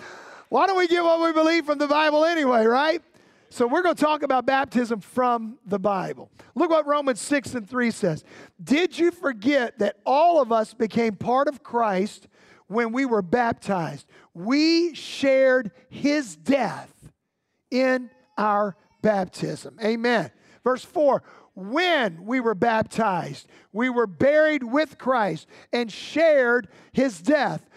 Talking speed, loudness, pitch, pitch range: 145 wpm, -23 LUFS, 255 Hz, 225-295 Hz